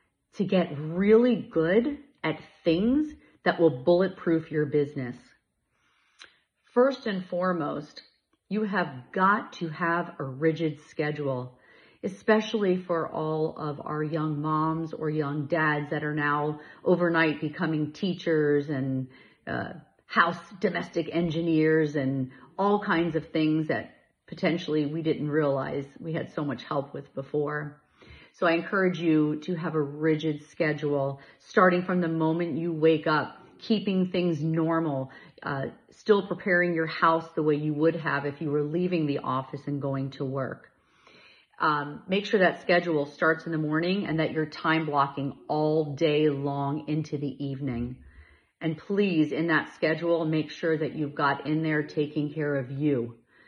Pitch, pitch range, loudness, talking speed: 155 Hz, 145-170 Hz, -27 LUFS, 150 wpm